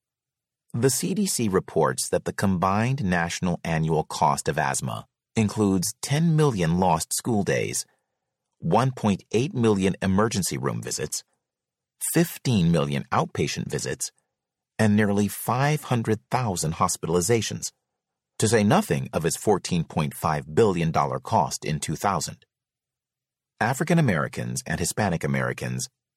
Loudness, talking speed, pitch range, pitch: -24 LUFS, 105 wpm, 85-130 Hz, 105 Hz